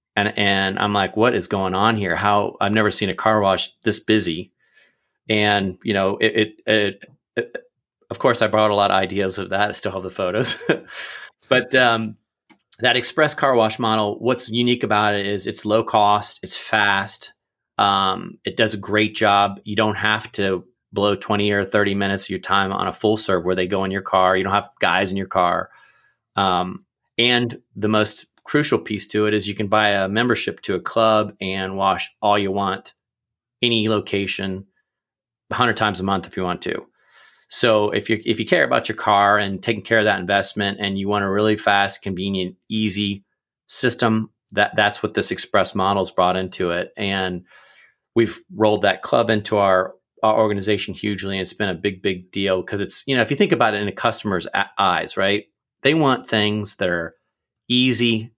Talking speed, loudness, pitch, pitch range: 200 wpm, -20 LUFS, 105 Hz, 95-110 Hz